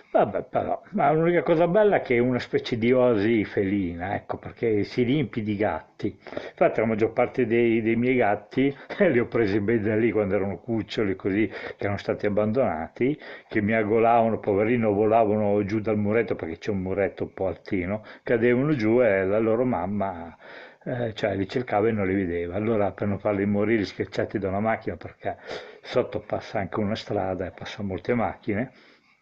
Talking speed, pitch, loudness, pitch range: 185 wpm, 110 Hz, -25 LUFS, 100-120 Hz